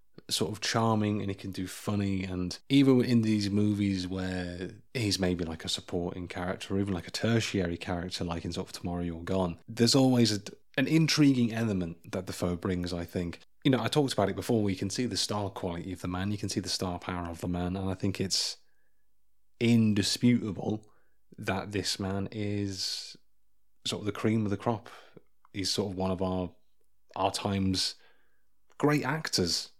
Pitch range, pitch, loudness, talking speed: 90-110 Hz, 100 Hz, -30 LUFS, 195 wpm